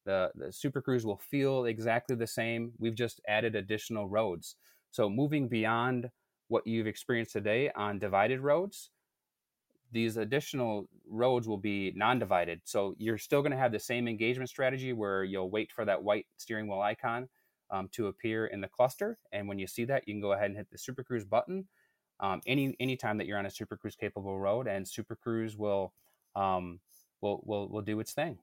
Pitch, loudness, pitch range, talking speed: 110 Hz, -34 LUFS, 105-125 Hz, 195 wpm